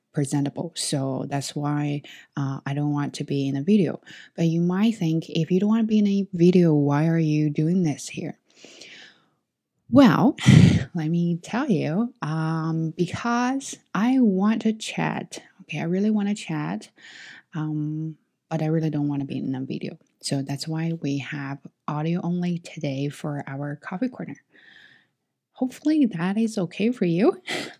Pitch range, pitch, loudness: 145-195 Hz, 160 Hz, -24 LUFS